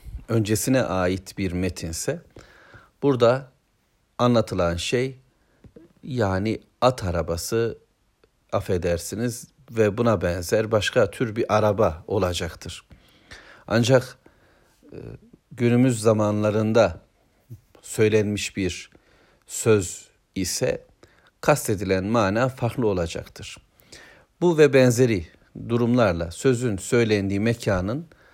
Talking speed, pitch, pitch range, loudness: 80 wpm, 110 Hz, 95-120 Hz, -23 LUFS